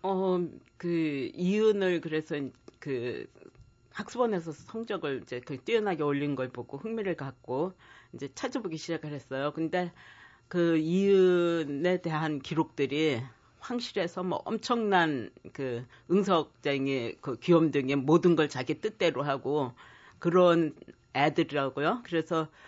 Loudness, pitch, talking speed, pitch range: -30 LUFS, 160 Hz, 255 characters per minute, 140-180 Hz